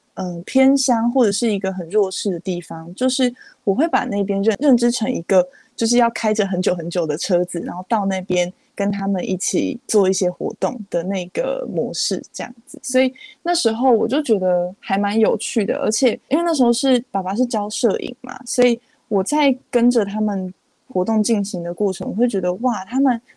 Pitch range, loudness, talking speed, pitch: 190-255 Hz, -19 LUFS, 290 characters per minute, 220 Hz